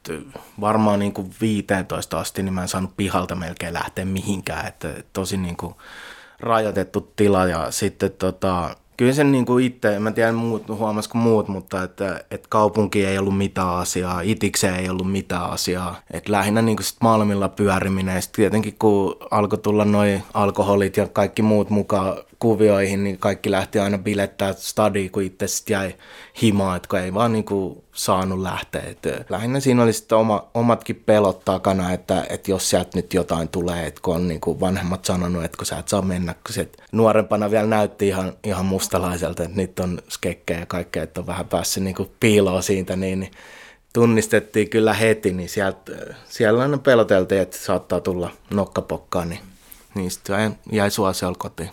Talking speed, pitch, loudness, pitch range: 170 wpm, 100 Hz, -21 LUFS, 95-105 Hz